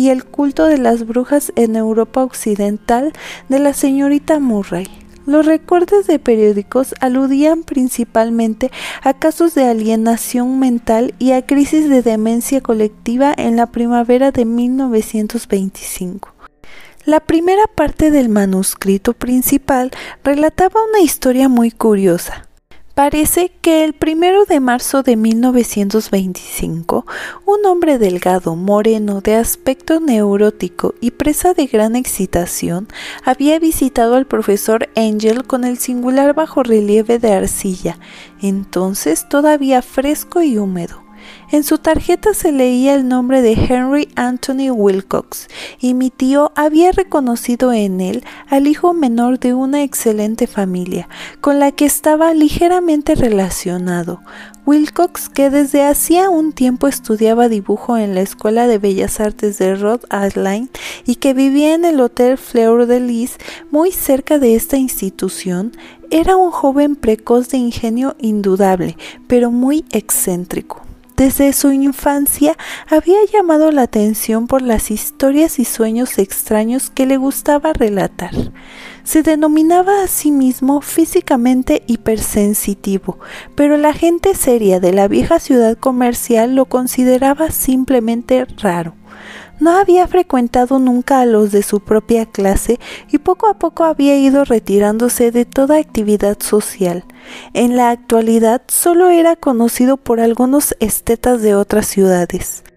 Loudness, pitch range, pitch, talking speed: -13 LUFS, 220-290 Hz, 250 Hz, 130 wpm